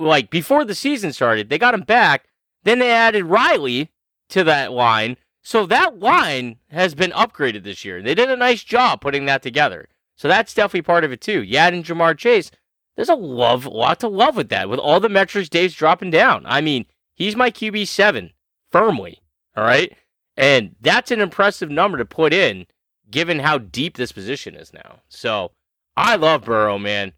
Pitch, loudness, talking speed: 170 Hz, -17 LUFS, 190 wpm